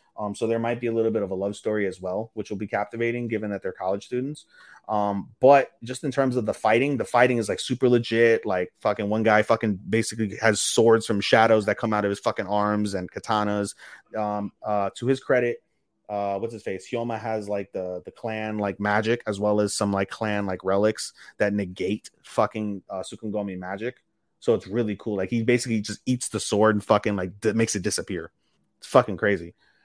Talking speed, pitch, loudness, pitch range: 215 wpm, 105 Hz, -25 LUFS, 100-115 Hz